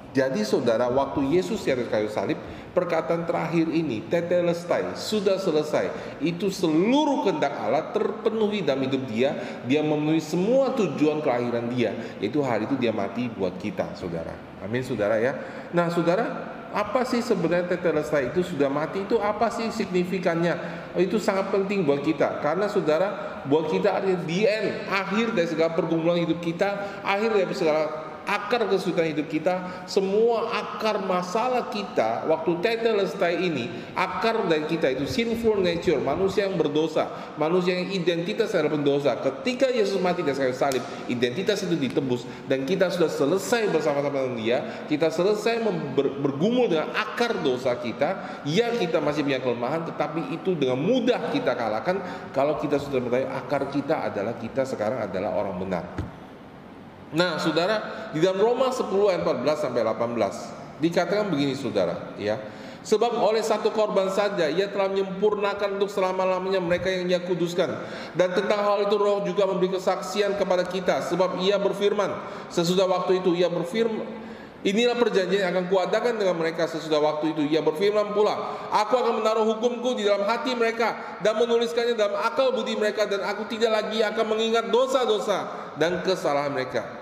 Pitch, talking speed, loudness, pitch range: 185 Hz, 155 wpm, -25 LUFS, 160-210 Hz